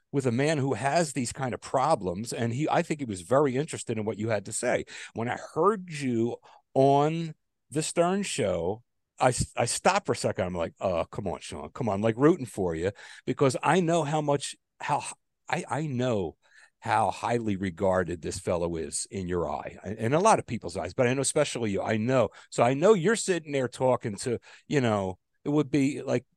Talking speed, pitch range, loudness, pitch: 215 wpm, 110-150 Hz, -28 LUFS, 130 Hz